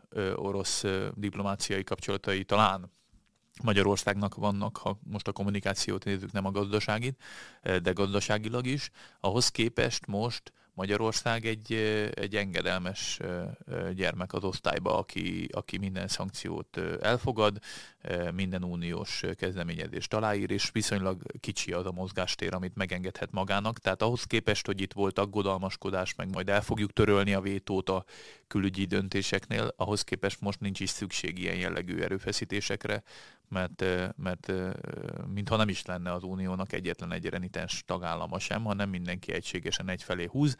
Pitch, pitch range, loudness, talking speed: 100 Hz, 95-105 Hz, -32 LUFS, 130 wpm